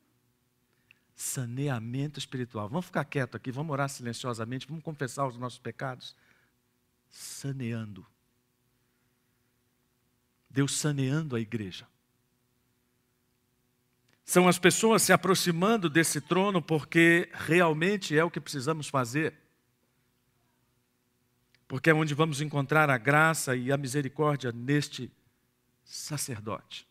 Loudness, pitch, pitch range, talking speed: -28 LUFS, 130 Hz, 125-155 Hz, 100 wpm